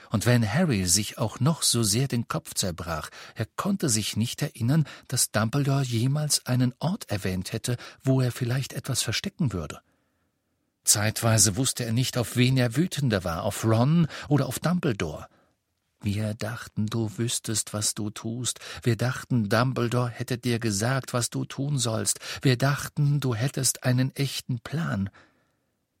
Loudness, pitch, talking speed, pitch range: -26 LUFS, 125 Hz, 155 wpm, 110-135 Hz